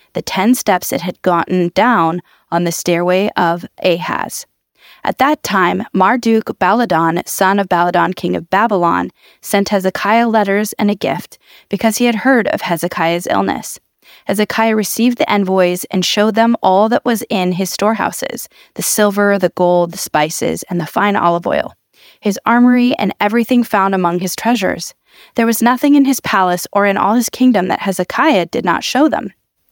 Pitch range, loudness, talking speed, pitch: 180-230 Hz, -14 LUFS, 170 wpm, 200 Hz